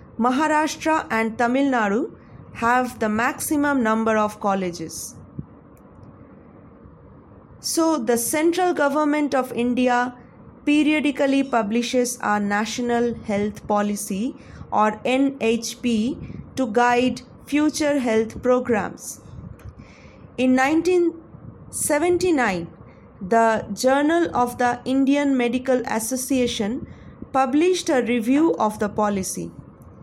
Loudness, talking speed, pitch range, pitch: -21 LUFS, 90 wpm, 225-285 Hz, 250 Hz